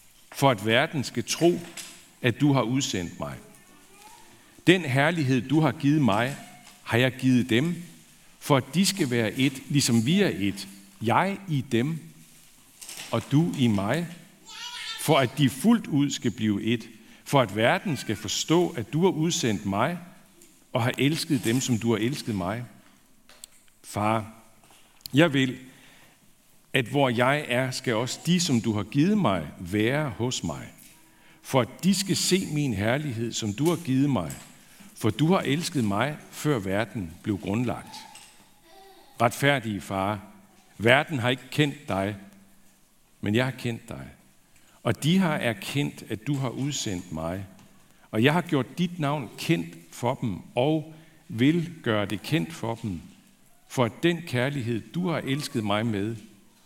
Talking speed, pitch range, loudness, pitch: 155 wpm, 110-150 Hz, -26 LUFS, 130 Hz